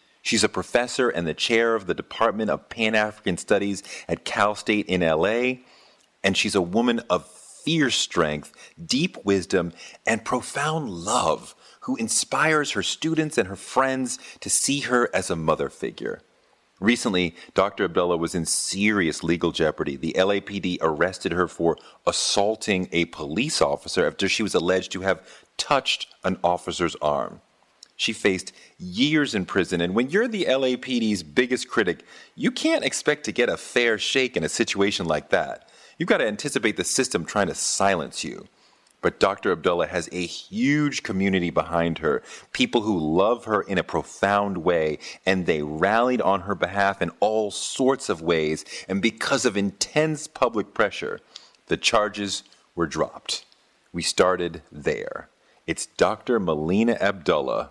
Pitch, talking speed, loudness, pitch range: 100 Hz, 155 wpm, -24 LUFS, 90-125 Hz